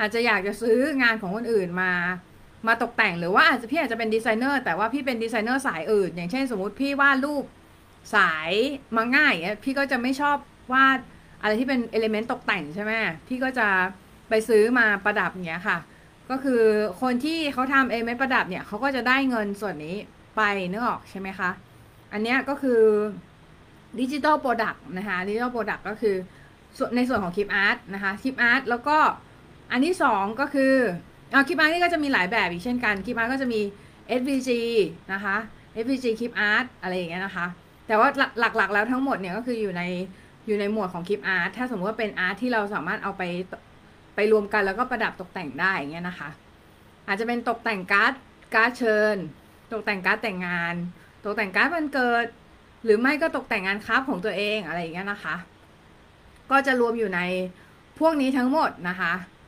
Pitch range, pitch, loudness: 195-255 Hz, 220 Hz, -24 LUFS